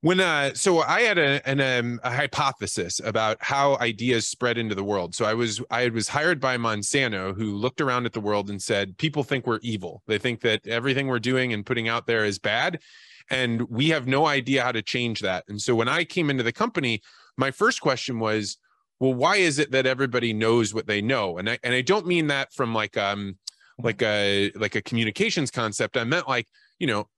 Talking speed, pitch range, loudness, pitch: 225 wpm, 110-135 Hz, -24 LUFS, 120 Hz